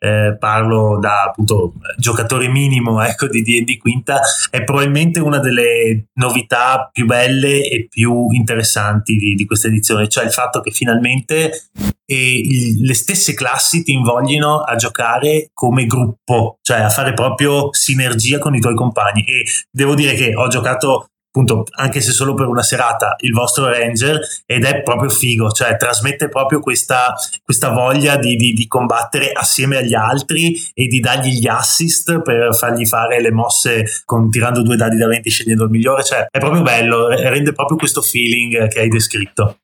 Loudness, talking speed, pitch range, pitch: -13 LUFS, 170 wpm, 115-135 Hz, 120 Hz